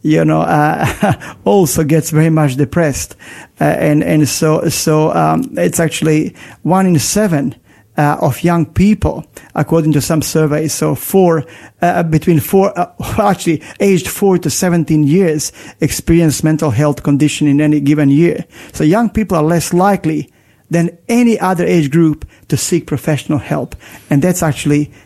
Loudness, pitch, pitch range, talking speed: -13 LUFS, 155 Hz, 150-175 Hz, 155 wpm